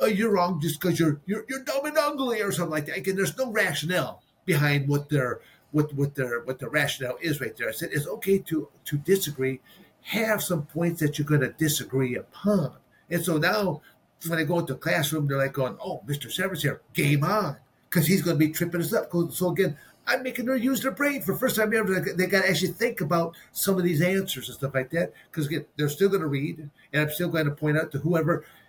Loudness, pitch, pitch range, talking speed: -26 LUFS, 170 Hz, 150-195 Hz, 230 wpm